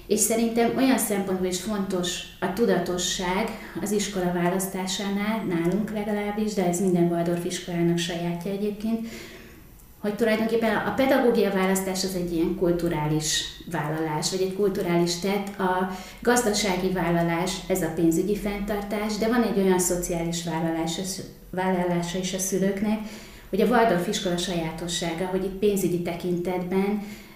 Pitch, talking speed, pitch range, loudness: 185 Hz, 135 wpm, 175-205 Hz, -25 LUFS